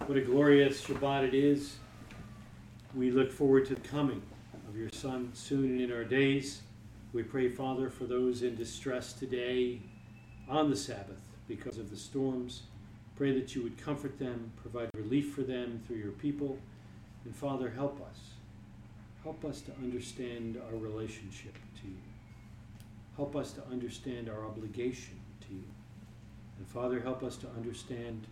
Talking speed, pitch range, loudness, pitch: 155 wpm, 110-130 Hz, -35 LUFS, 120 Hz